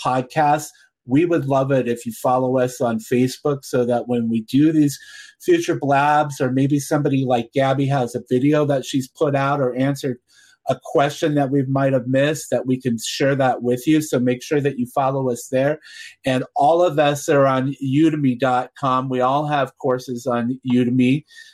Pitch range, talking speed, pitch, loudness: 125-145 Hz, 190 wpm, 135 Hz, -19 LUFS